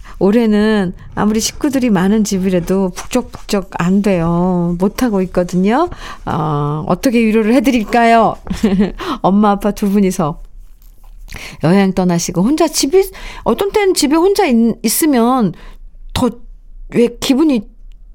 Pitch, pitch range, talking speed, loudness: 210 Hz, 190-245 Hz, 260 characters per minute, -14 LUFS